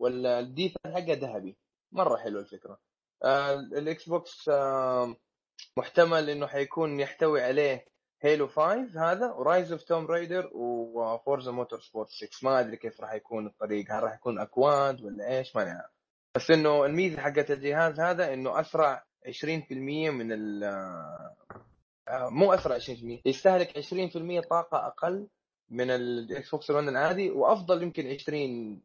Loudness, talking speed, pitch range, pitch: -29 LUFS, 140 wpm, 125-165 Hz, 145 Hz